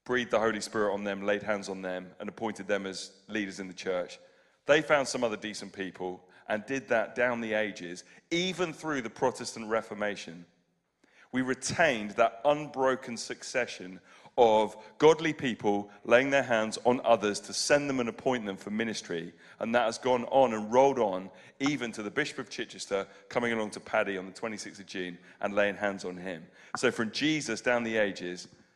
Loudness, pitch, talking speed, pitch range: -30 LUFS, 110 Hz, 190 wpm, 100-125 Hz